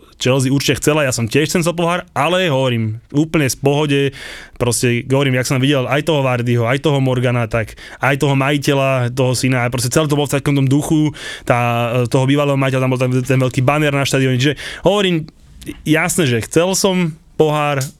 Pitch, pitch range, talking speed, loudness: 140 Hz, 130-150 Hz, 195 wpm, -16 LUFS